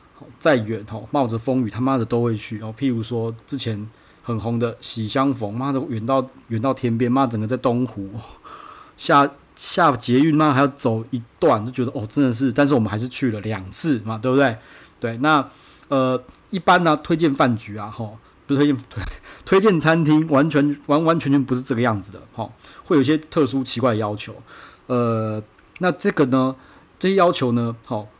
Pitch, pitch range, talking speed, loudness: 125 Hz, 115-140 Hz, 270 characters per minute, -20 LUFS